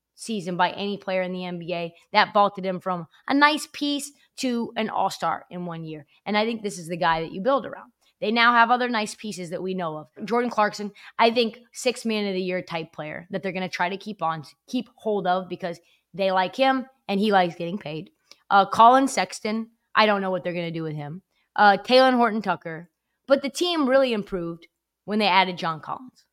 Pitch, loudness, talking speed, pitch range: 195 Hz, -23 LUFS, 225 wpm, 180-230 Hz